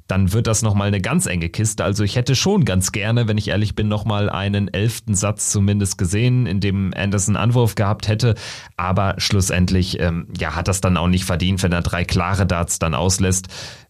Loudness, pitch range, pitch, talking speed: -19 LUFS, 95-110 Hz, 100 Hz, 205 wpm